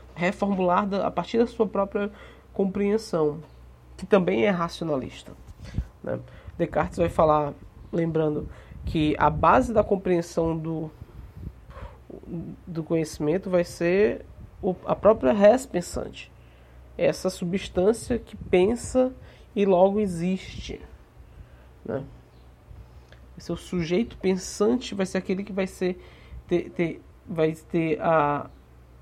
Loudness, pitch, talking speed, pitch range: -25 LUFS, 175 Hz, 110 wpm, 150-195 Hz